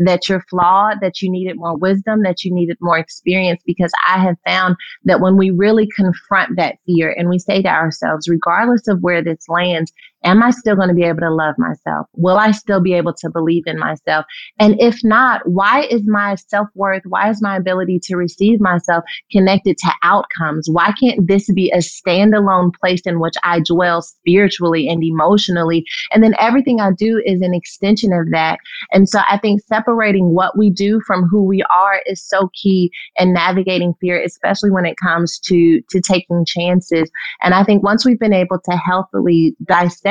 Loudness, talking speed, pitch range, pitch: -14 LUFS, 195 wpm, 175-200 Hz, 185 Hz